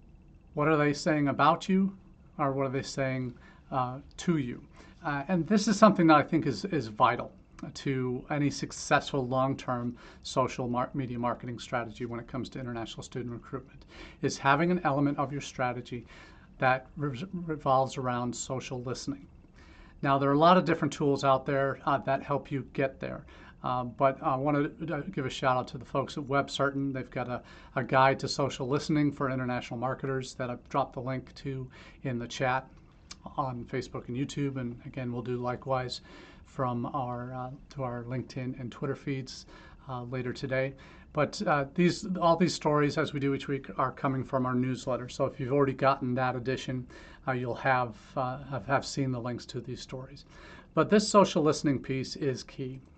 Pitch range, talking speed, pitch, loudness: 125-145 Hz, 190 wpm, 135 Hz, -30 LUFS